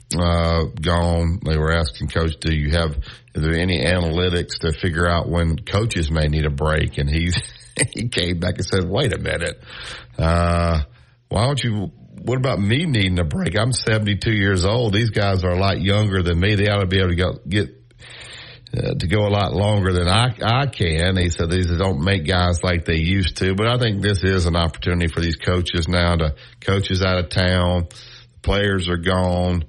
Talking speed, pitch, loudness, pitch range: 205 wpm, 90 Hz, -20 LUFS, 85-105 Hz